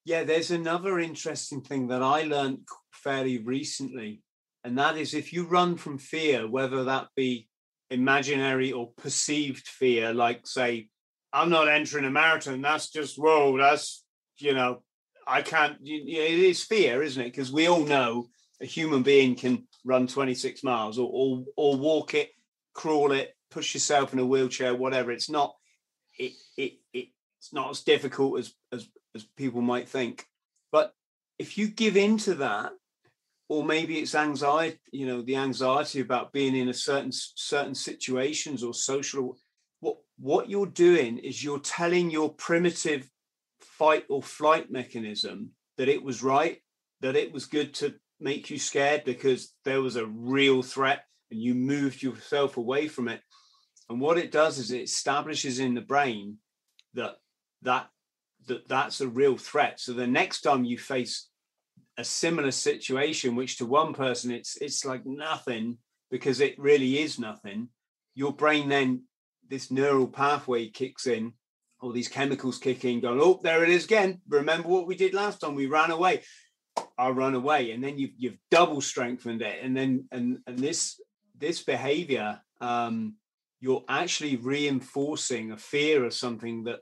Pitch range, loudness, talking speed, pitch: 125-155 Hz, -27 LUFS, 165 wpm, 135 Hz